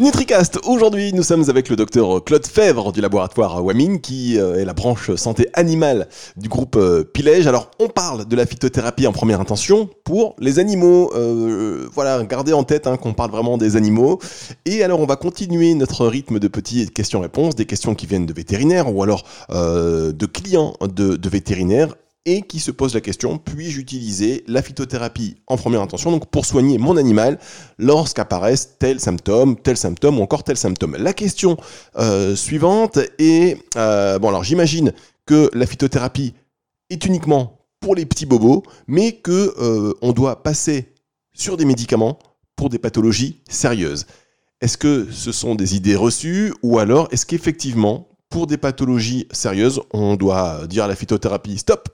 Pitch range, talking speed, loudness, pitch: 110-155 Hz, 170 wpm, -17 LUFS, 125 Hz